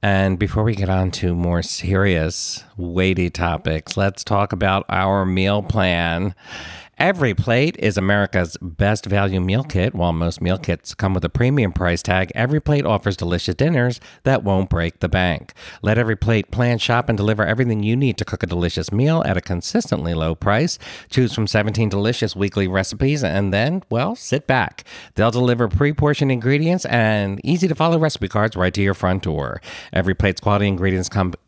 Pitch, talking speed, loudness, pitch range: 100 Hz, 185 wpm, -19 LUFS, 90-120 Hz